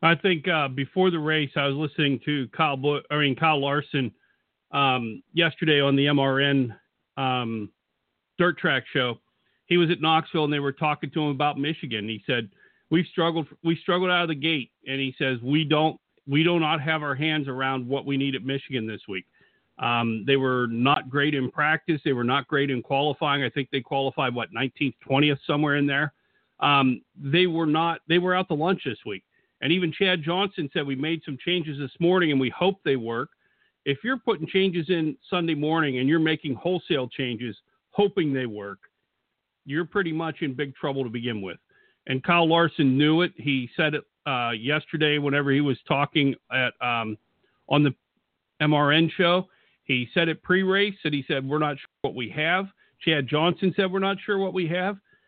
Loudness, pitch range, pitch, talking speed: -24 LUFS, 135-165 Hz, 145 Hz, 200 wpm